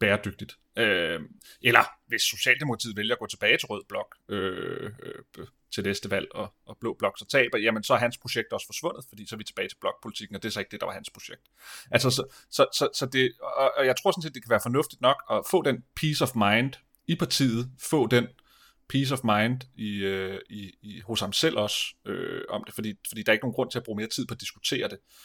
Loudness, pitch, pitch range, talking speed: -27 LUFS, 115 Hz, 105-130 Hz, 245 wpm